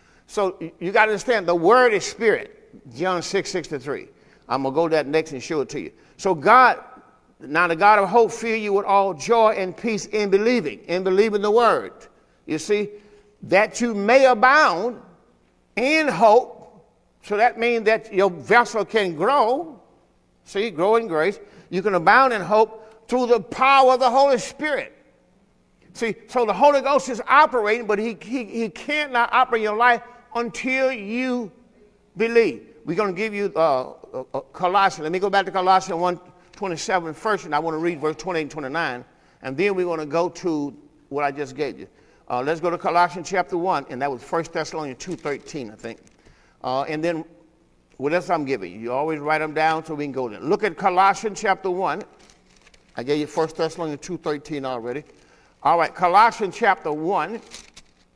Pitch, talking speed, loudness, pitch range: 195 Hz, 190 wpm, -21 LUFS, 160-225 Hz